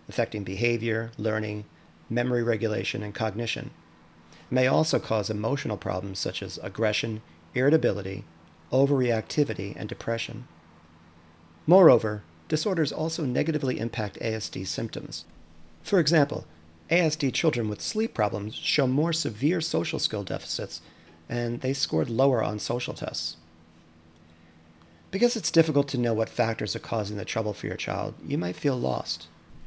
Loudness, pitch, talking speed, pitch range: -27 LUFS, 110 Hz, 130 wpm, 85-130 Hz